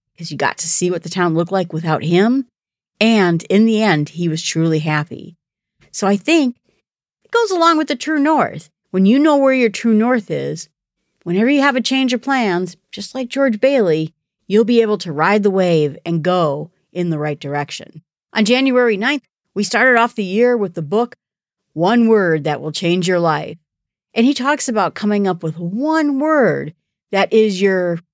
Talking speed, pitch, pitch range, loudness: 195 wpm, 195 Hz, 165-240 Hz, -16 LUFS